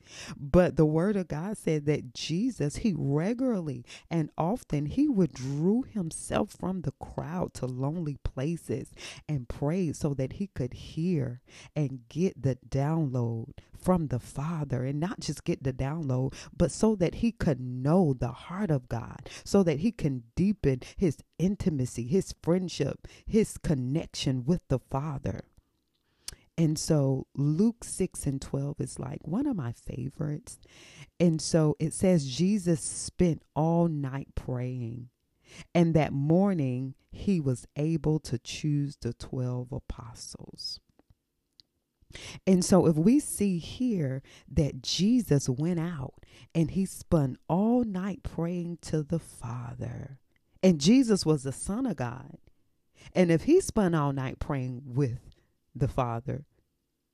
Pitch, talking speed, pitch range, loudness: 150 Hz, 140 wpm, 130-175 Hz, -29 LUFS